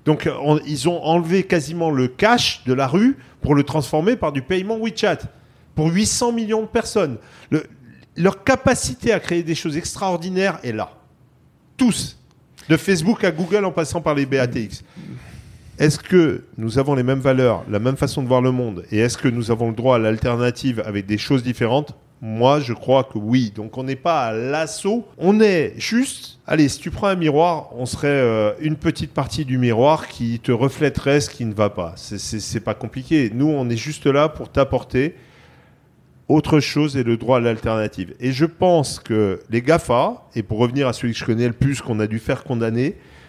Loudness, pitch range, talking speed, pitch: -20 LUFS, 120-165 Hz, 200 wpm, 140 Hz